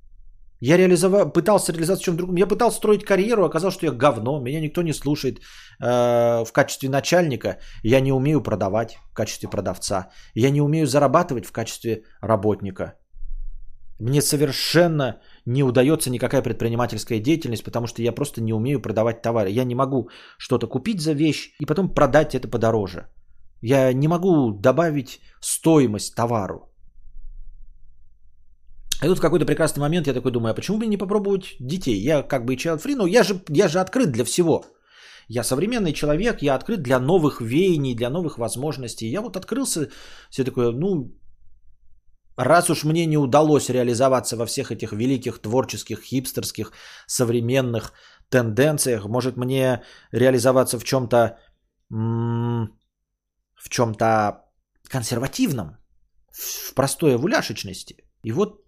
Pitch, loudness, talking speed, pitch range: 130 Hz, -21 LUFS, 145 wpm, 115-155 Hz